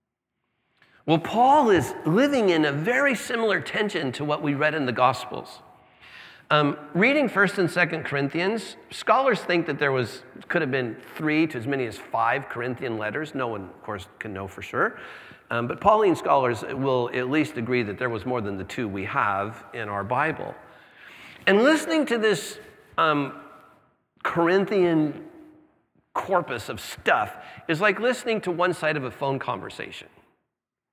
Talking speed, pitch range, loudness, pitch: 165 wpm, 130-200 Hz, -24 LUFS, 155 Hz